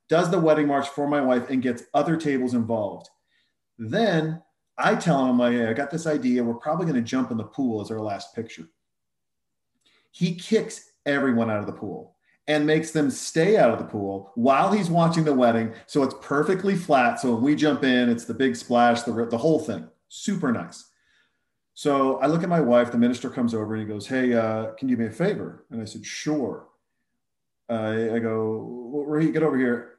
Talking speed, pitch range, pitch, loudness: 210 wpm, 115-150 Hz, 125 Hz, -24 LUFS